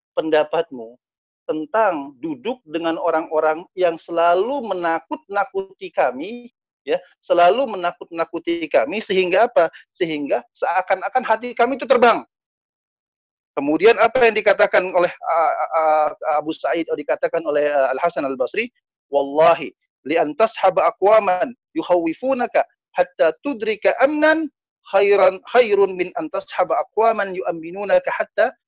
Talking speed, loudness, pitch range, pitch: 115 wpm, -19 LUFS, 165-255 Hz, 195 Hz